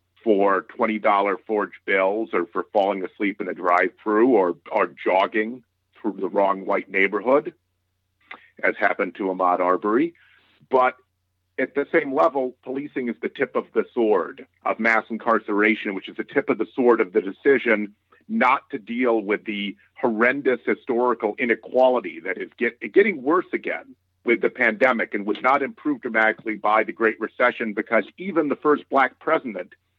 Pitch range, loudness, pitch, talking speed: 100-130 Hz, -22 LUFS, 110 Hz, 160 wpm